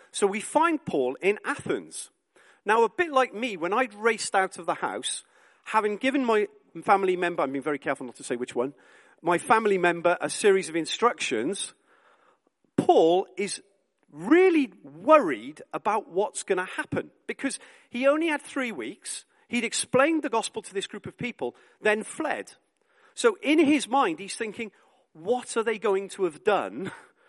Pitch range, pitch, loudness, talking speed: 185-295 Hz, 225 Hz, -26 LUFS, 170 wpm